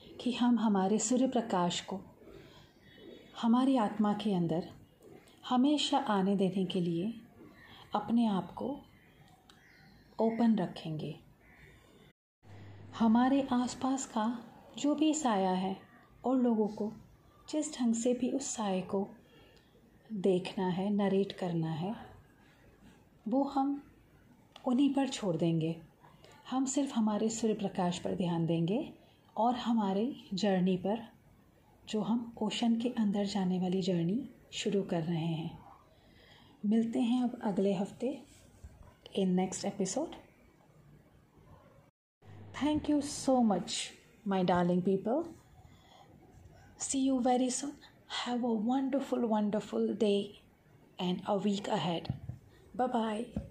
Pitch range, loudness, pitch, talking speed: 185-250 Hz, -33 LUFS, 215 Hz, 115 wpm